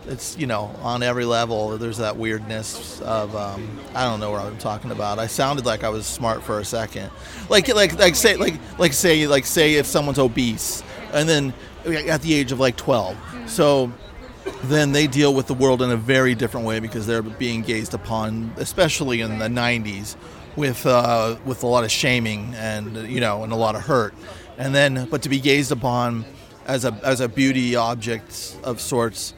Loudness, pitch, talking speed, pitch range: -21 LUFS, 120 Hz, 200 wpm, 110-135 Hz